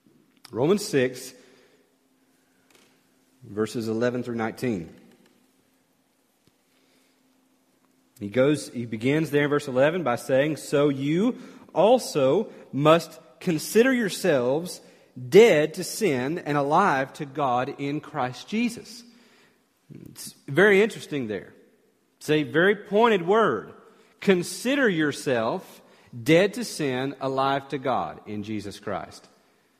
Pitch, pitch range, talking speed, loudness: 150 Hz, 130-200 Hz, 105 wpm, -24 LUFS